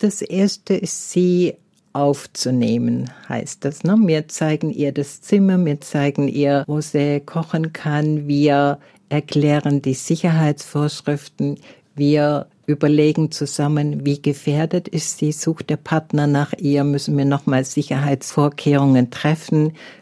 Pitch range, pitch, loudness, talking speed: 140-160 Hz, 150 Hz, -19 LUFS, 120 wpm